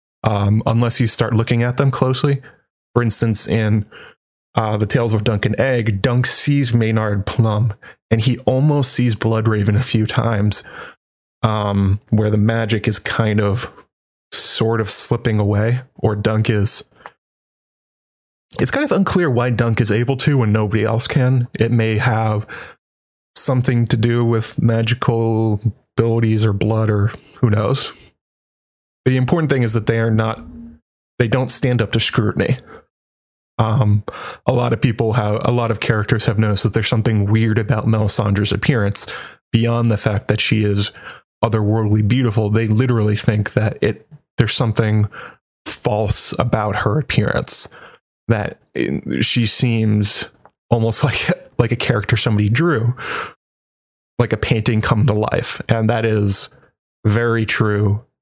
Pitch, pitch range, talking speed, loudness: 115 Hz, 105-120 Hz, 150 wpm, -17 LUFS